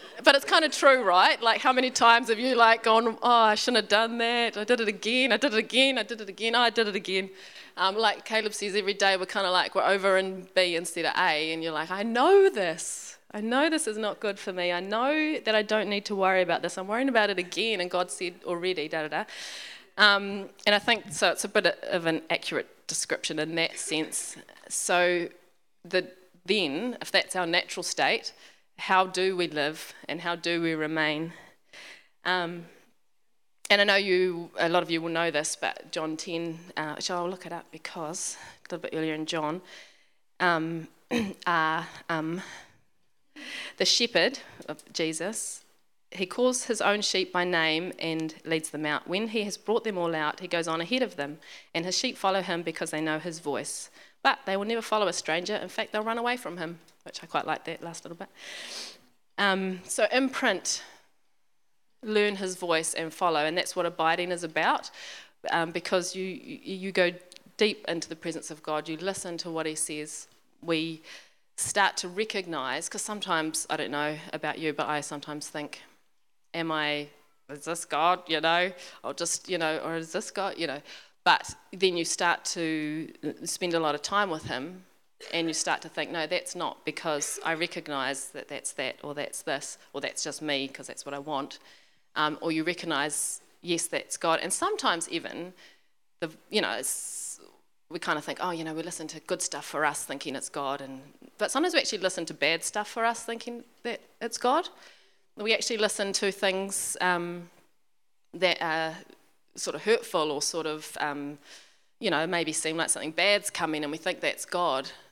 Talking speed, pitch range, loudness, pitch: 200 wpm, 160-210 Hz, -27 LUFS, 180 Hz